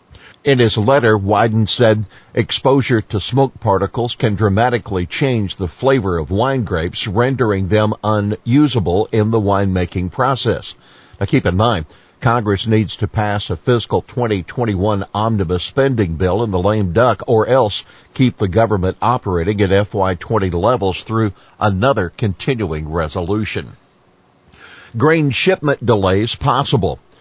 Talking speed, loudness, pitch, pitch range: 130 wpm, -16 LUFS, 105 Hz, 95-120 Hz